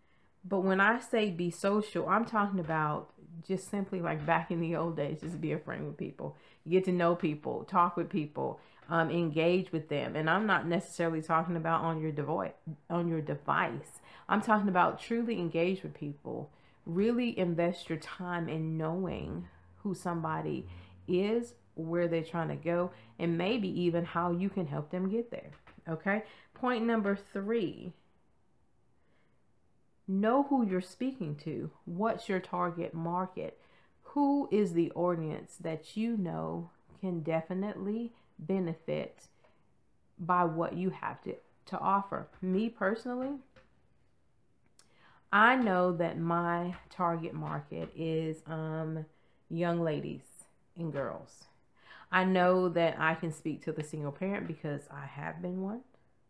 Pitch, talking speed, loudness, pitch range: 175 Hz, 145 wpm, -33 LUFS, 160-195 Hz